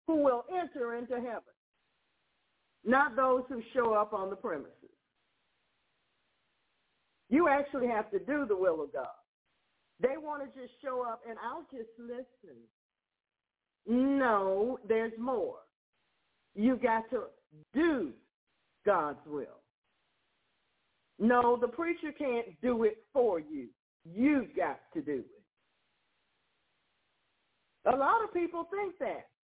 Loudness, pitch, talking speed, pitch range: -32 LUFS, 255 Hz, 120 wpm, 230-300 Hz